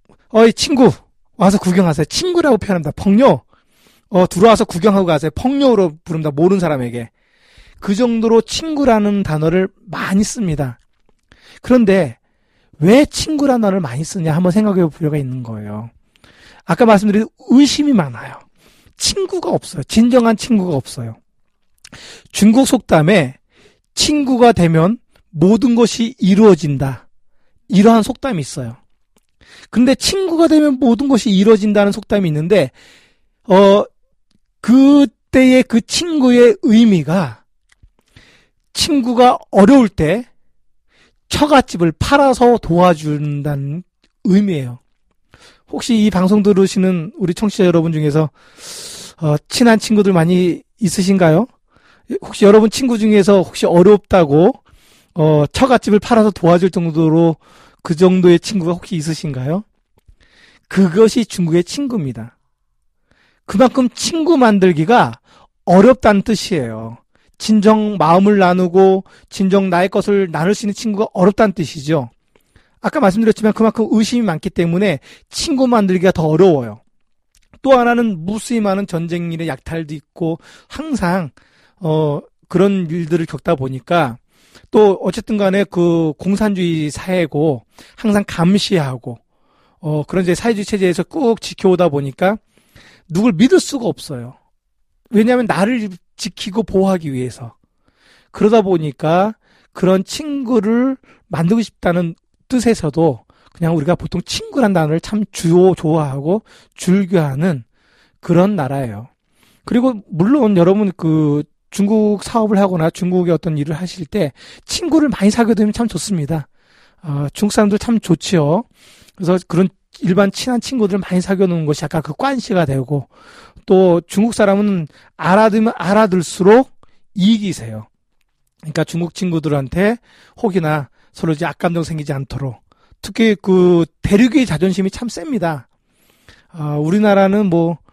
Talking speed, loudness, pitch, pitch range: 290 characters per minute, -14 LUFS, 190 Hz, 165-225 Hz